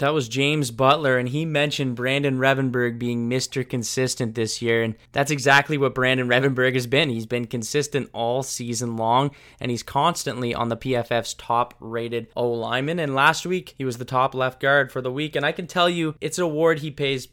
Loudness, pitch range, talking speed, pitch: -22 LUFS, 120-140 Hz, 210 wpm, 130 Hz